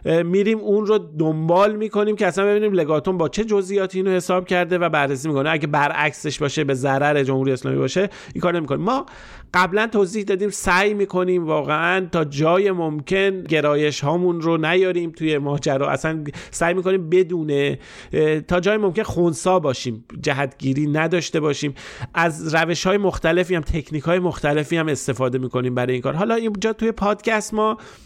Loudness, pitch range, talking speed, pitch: -20 LUFS, 150-190 Hz, 165 wpm, 170 Hz